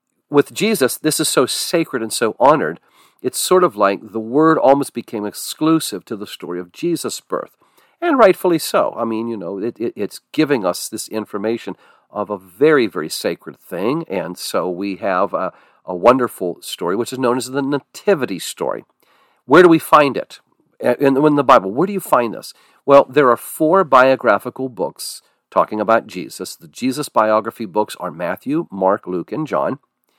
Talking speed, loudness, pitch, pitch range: 185 wpm, -17 LUFS, 135 Hz, 110-160 Hz